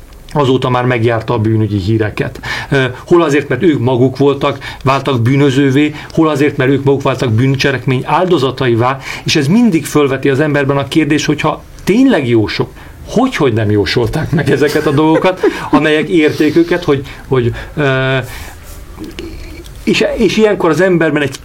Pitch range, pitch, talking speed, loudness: 125-155 Hz, 140 Hz, 150 wpm, -12 LUFS